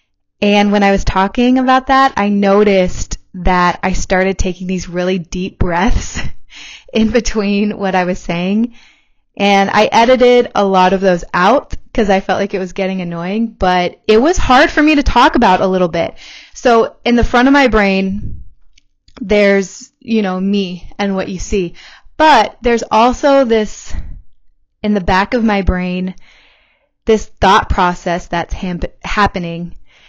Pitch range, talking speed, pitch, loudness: 185-230 Hz, 165 wpm, 200 Hz, -13 LUFS